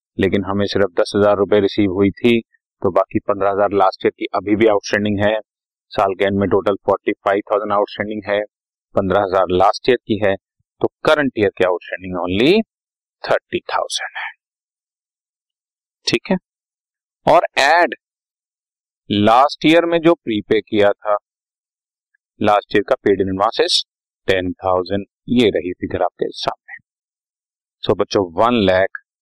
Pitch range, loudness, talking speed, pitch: 100-105 Hz, -17 LUFS, 145 wpm, 100 Hz